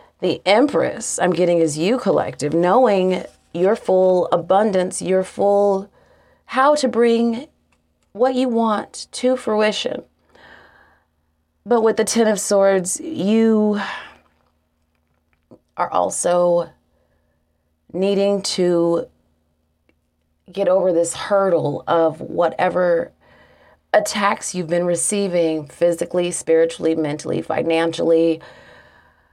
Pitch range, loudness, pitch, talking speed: 160-205 Hz, -18 LUFS, 180 Hz, 95 wpm